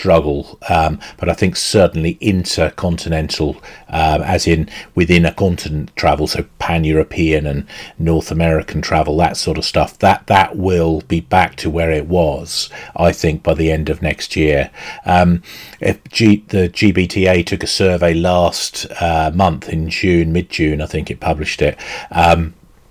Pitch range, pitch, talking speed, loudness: 80-90 Hz, 85 Hz, 160 wpm, -15 LUFS